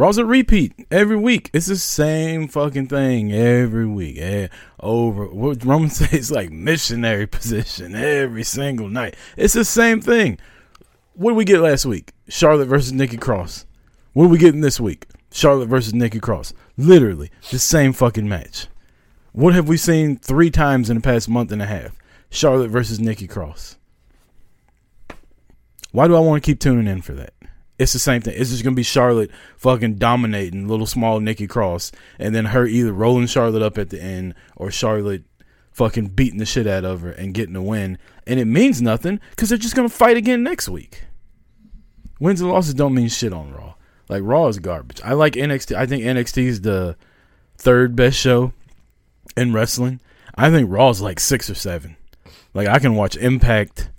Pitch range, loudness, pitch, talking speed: 105-145 Hz, -17 LUFS, 120 Hz, 185 wpm